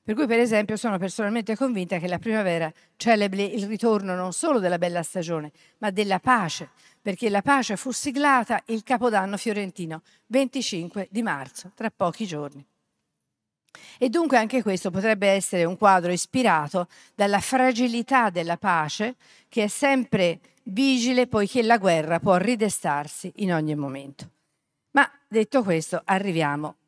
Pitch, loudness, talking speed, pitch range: 205 Hz, -24 LUFS, 145 wpm, 175-235 Hz